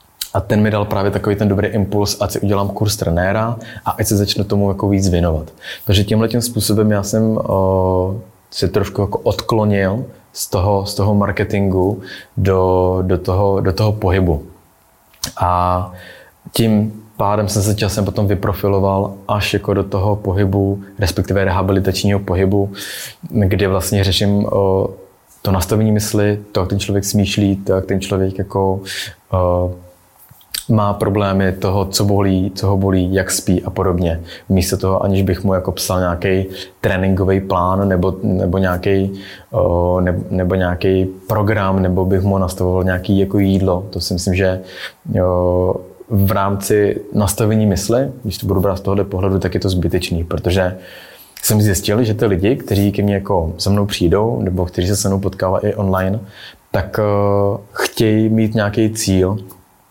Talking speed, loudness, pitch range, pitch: 155 wpm, -16 LUFS, 95-105 Hz, 100 Hz